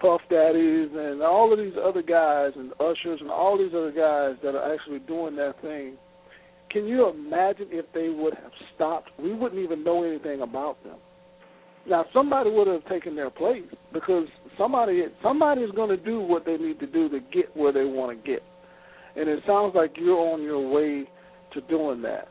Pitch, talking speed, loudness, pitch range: 170 Hz, 195 wpm, -25 LUFS, 155-190 Hz